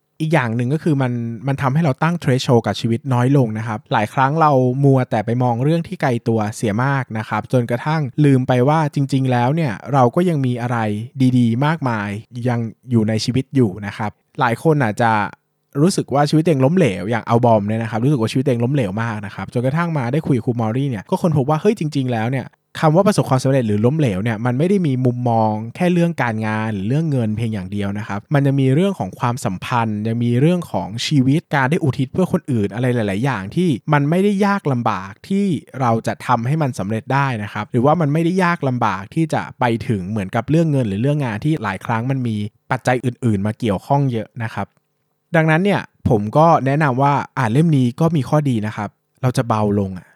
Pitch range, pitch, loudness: 115-150 Hz, 130 Hz, -18 LUFS